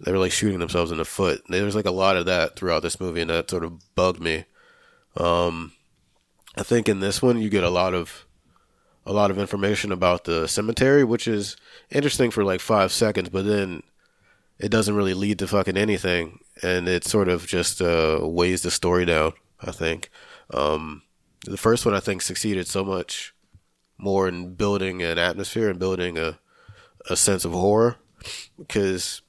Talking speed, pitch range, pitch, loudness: 190 wpm, 85-105 Hz, 95 Hz, -23 LUFS